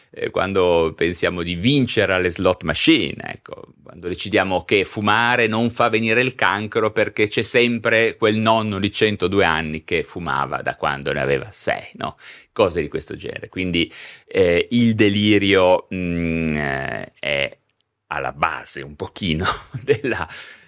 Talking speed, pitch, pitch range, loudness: 140 wpm, 100 Hz, 90-115 Hz, -19 LUFS